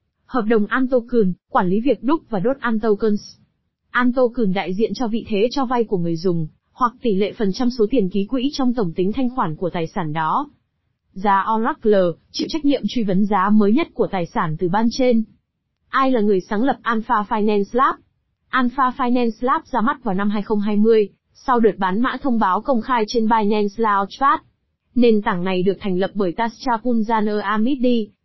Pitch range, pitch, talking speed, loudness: 200-250 Hz, 225 Hz, 195 wpm, -20 LUFS